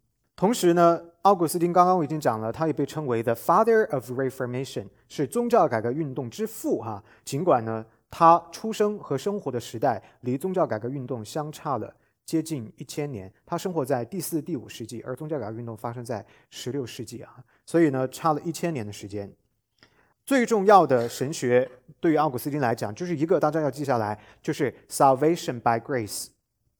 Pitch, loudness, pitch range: 140 Hz, -25 LUFS, 120-165 Hz